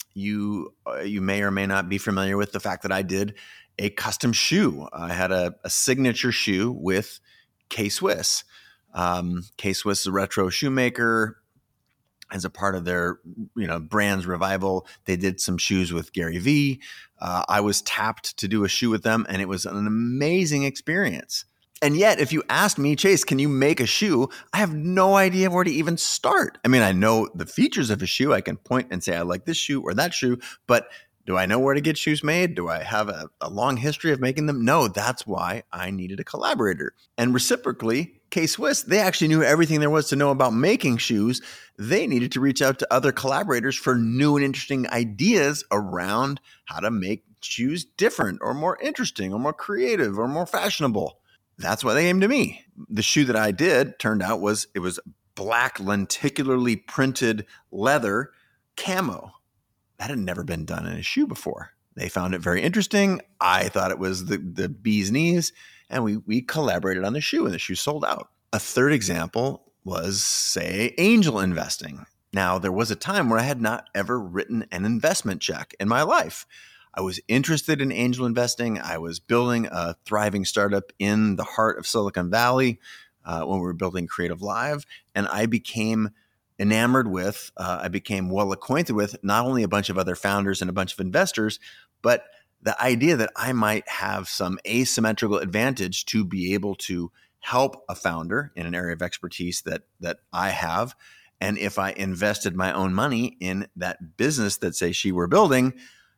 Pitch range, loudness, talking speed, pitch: 95-135 Hz, -23 LUFS, 195 wpm, 110 Hz